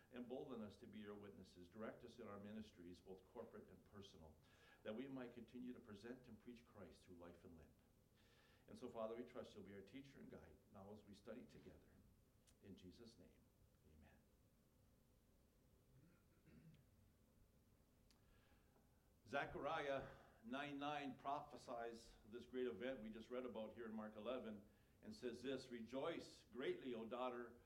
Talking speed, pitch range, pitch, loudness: 150 wpm, 100-125 Hz, 115 Hz, -54 LUFS